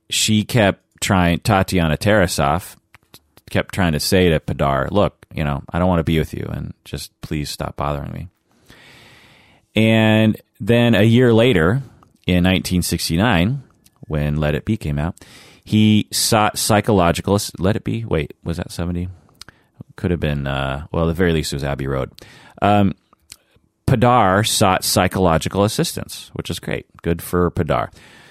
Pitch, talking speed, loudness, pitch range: 90 Hz, 155 wpm, -18 LUFS, 80-110 Hz